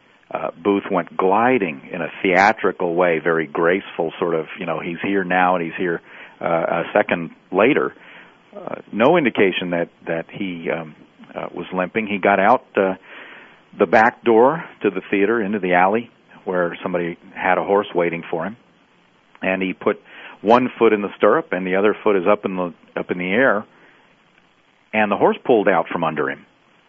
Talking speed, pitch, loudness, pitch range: 185 wpm, 95 Hz, -19 LUFS, 85-100 Hz